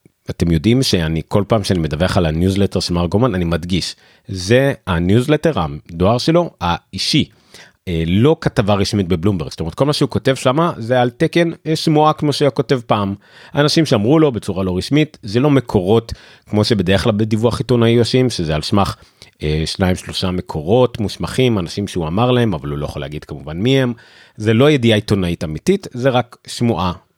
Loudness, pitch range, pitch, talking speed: -16 LUFS, 90-130 Hz, 110 Hz, 180 wpm